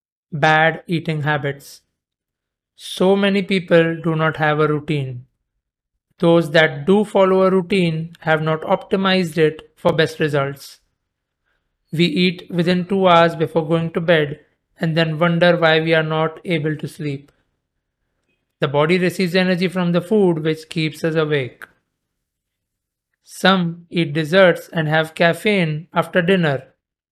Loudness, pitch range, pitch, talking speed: -17 LUFS, 155-180 Hz, 165 Hz, 135 wpm